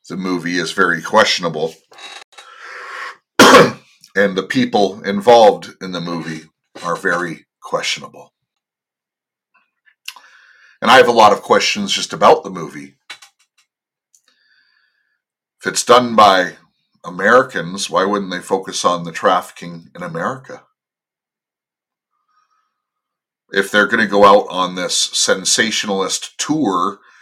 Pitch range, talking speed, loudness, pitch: 85-105 Hz, 110 wpm, -14 LUFS, 95 Hz